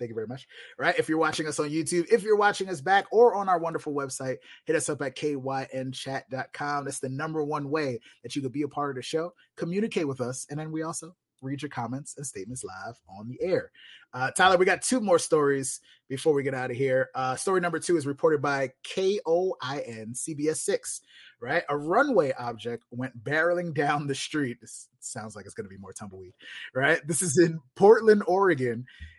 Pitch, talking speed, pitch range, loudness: 145 Hz, 210 wpm, 130-170 Hz, -27 LUFS